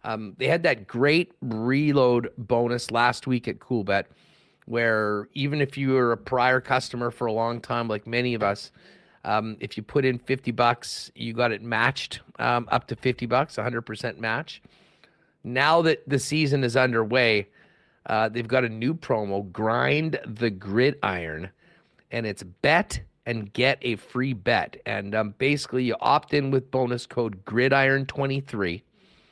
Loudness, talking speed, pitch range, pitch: -25 LUFS, 160 wpm, 110-130 Hz, 120 Hz